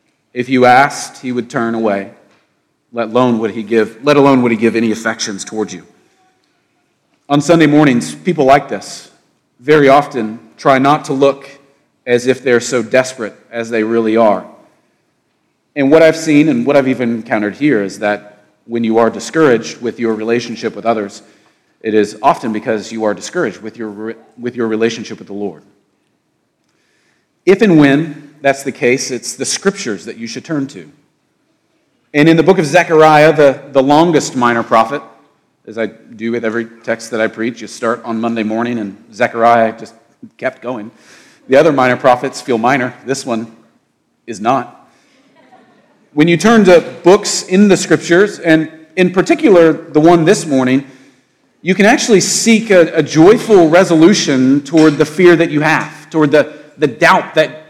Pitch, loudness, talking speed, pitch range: 130 Hz, -12 LUFS, 175 wpm, 115-155 Hz